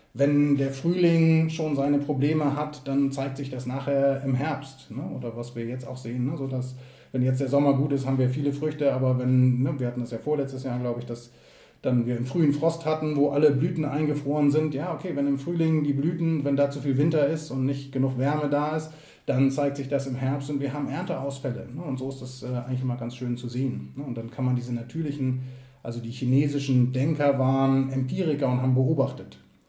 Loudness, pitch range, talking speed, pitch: -26 LUFS, 130-145 Hz, 230 wpm, 135 Hz